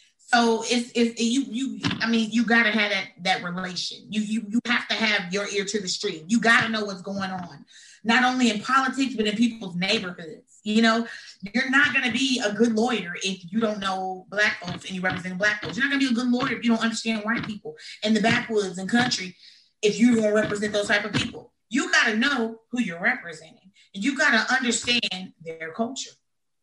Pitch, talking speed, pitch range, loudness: 220 Hz, 215 wpm, 195-235 Hz, -23 LUFS